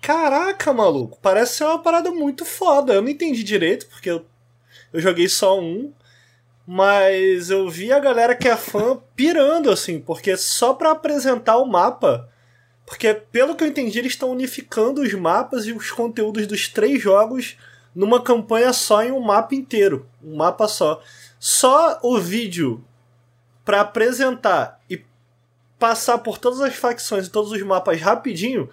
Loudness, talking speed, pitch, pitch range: -19 LUFS, 160 wpm, 220 Hz, 185-260 Hz